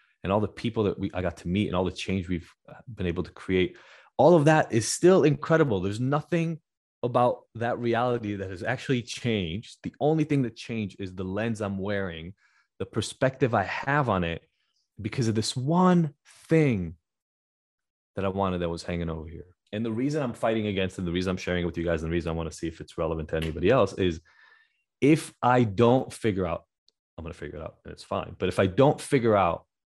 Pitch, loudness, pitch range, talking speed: 105 Hz, -26 LUFS, 90-130 Hz, 225 wpm